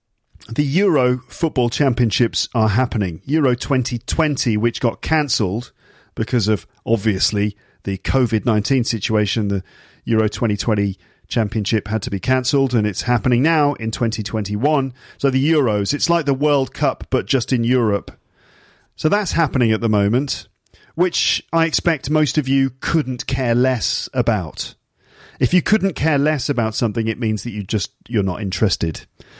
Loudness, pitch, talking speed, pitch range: -19 LUFS, 120 Hz, 150 wpm, 110-140 Hz